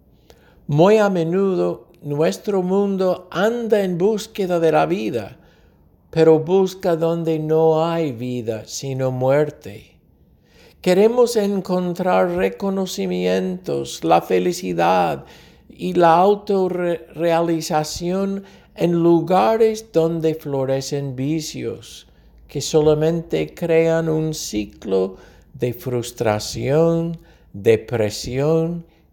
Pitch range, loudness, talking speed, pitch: 130-180 Hz, -19 LUFS, 80 wpm, 160 Hz